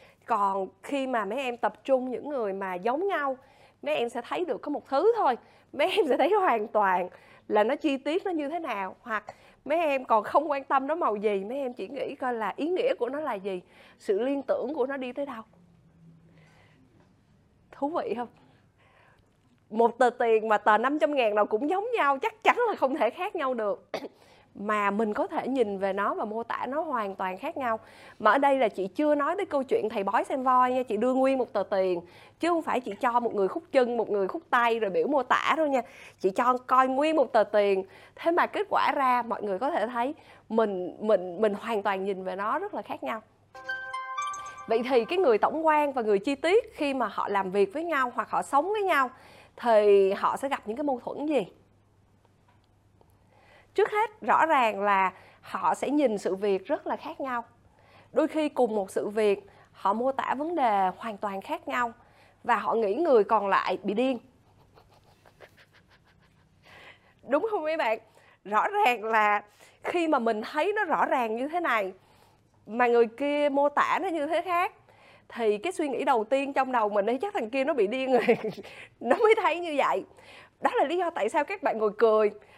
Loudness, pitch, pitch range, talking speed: -27 LUFS, 245 Hz, 205-300 Hz, 215 wpm